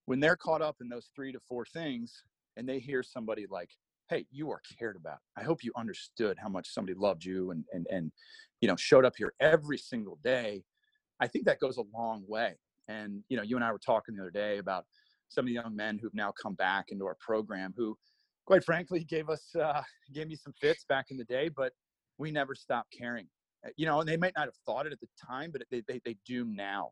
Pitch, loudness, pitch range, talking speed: 130 Hz, -34 LUFS, 110-155 Hz, 245 wpm